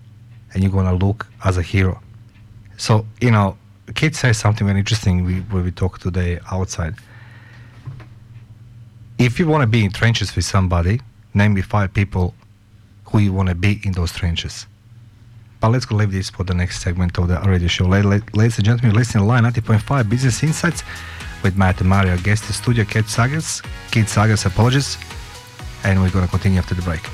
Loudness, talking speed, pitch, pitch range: -18 LUFS, 175 wpm, 105 Hz, 95-115 Hz